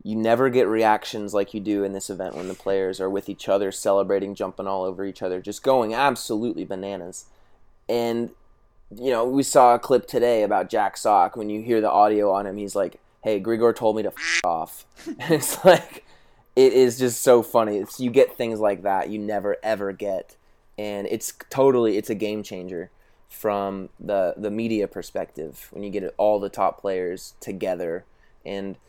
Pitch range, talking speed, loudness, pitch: 100-115 Hz, 195 wpm, -23 LUFS, 105 Hz